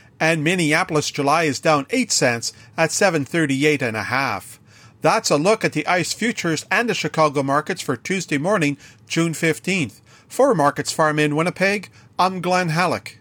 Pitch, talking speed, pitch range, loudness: 155 Hz, 165 wpm, 140-180 Hz, -20 LUFS